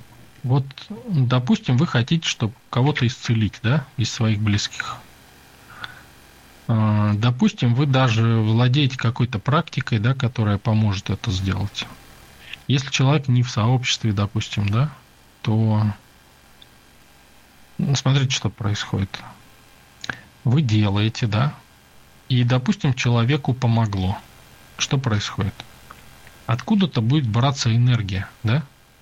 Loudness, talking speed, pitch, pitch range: -21 LUFS, 100 wpm, 115 Hz, 100-130 Hz